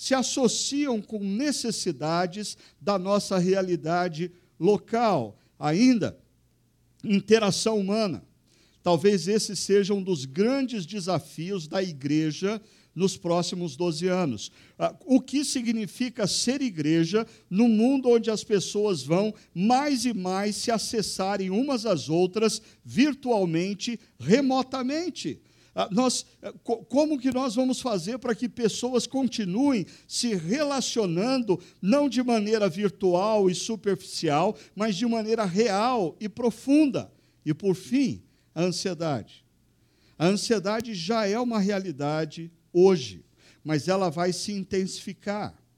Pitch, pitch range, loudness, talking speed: 205 Hz, 180-235 Hz, -26 LUFS, 115 wpm